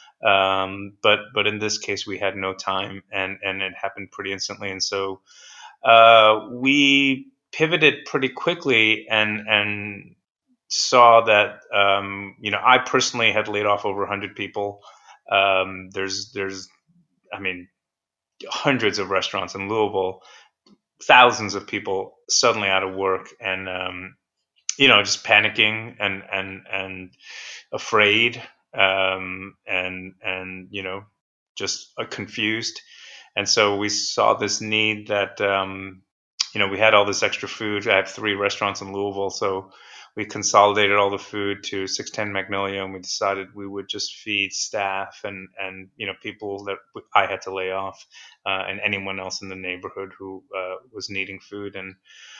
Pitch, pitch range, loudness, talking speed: 100 Hz, 95-105 Hz, -21 LUFS, 155 wpm